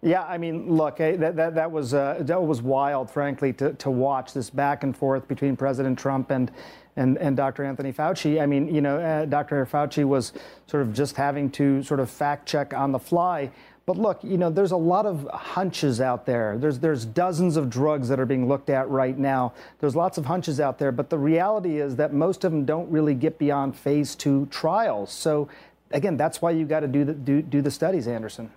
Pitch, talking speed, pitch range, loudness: 145 Hz, 225 wpm, 135-160 Hz, -24 LUFS